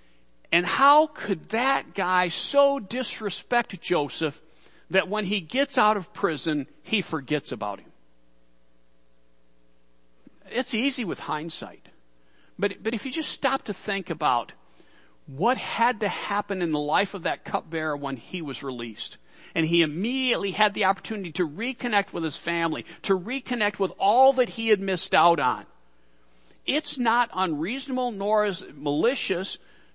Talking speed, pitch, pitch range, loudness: 150 wpm, 190 Hz, 150-230 Hz, -25 LUFS